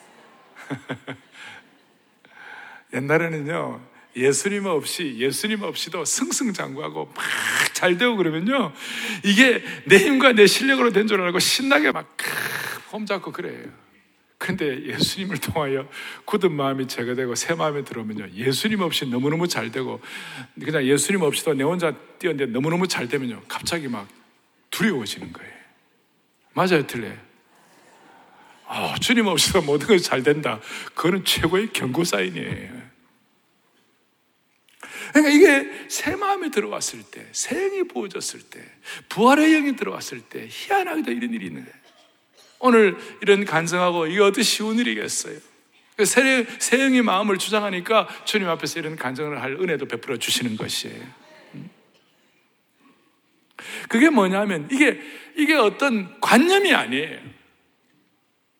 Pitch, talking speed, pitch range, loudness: 200 Hz, 285 characters per minute, 160-250 Hz, -21 LUFS